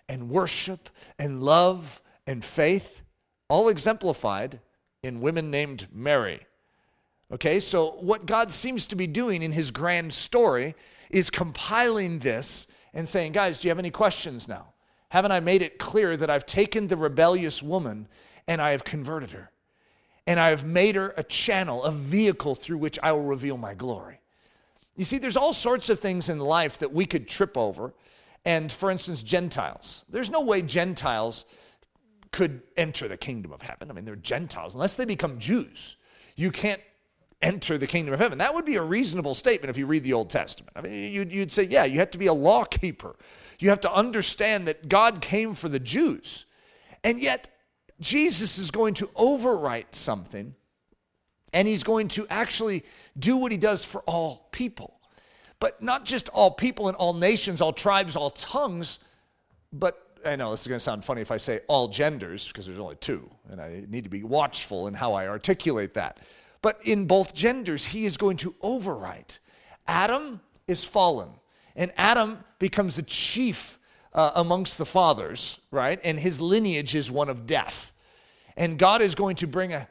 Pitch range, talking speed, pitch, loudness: 150-205 Hz, 180 wpm, 180 Hz, -25 LUFS